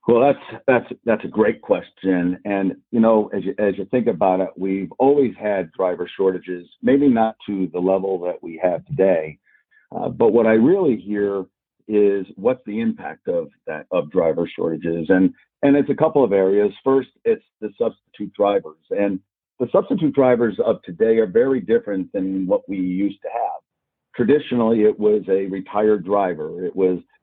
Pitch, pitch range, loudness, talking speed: 105 Hz, 95-135 Hz, -20 LUFS, 180 wpm